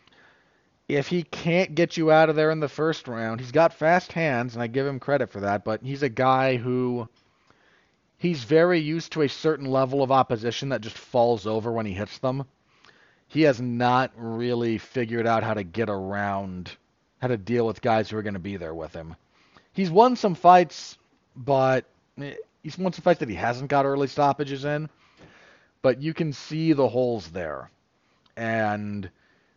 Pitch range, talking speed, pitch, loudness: 115-155 Hz, 185 wpm, 130 Hz, -24 LUFS